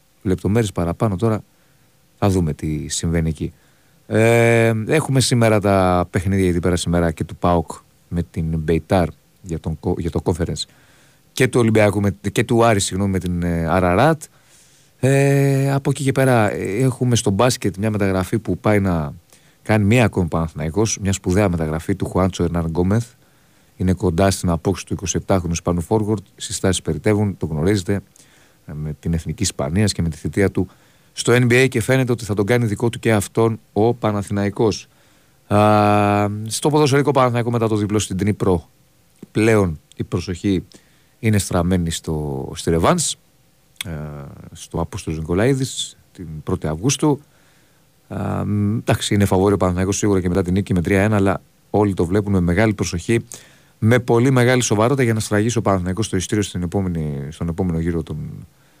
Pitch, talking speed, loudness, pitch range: 100 Hz, 155 wpm, -19 LUFS, 90-115 Hz